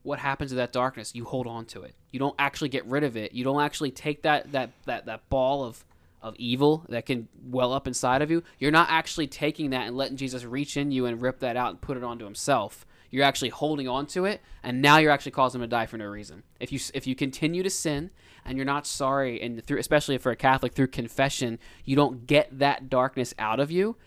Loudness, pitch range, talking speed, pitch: -27 LUFS, 125-145 Hz, 250 wpm, 135 Hz